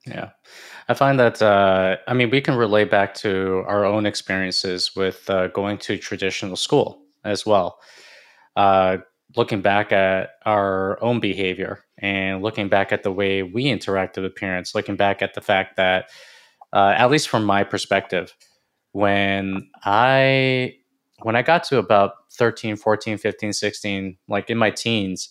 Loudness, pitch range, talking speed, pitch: -20 LUFS, 95-110 Hz, 160 wpm, 100 Hz